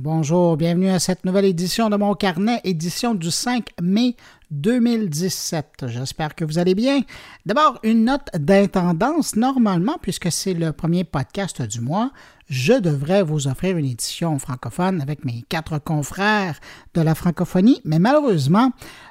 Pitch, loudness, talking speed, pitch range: 180 Hz, -20 LUFS, 150 wpm, 155-210 Hz